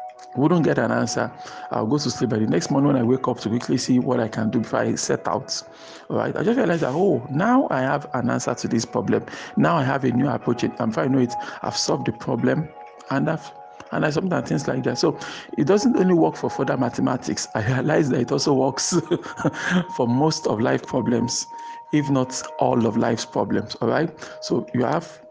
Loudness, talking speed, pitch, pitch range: -22 LUFS, 225 wpm, 125 Hz, 110-155 Hz